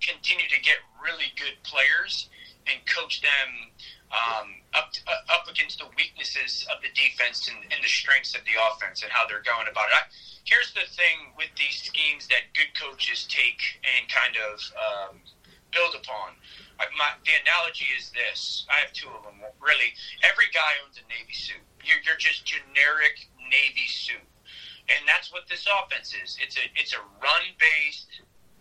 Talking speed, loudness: 180 wpm, -24 LUFS